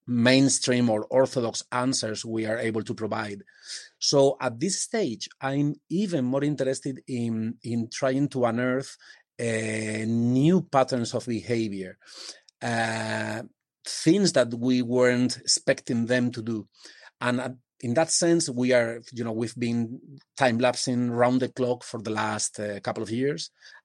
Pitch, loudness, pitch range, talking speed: 125 Hz, -26 LUFS, 115-135 Hz, 145 wpm